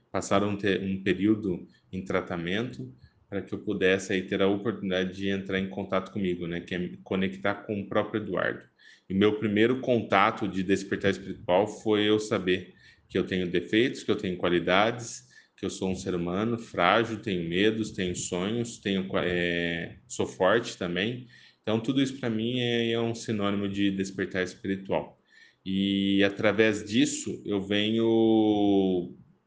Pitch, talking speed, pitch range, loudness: 100 Hz, 165 wpm, 95-110 Hz, -28 LUFS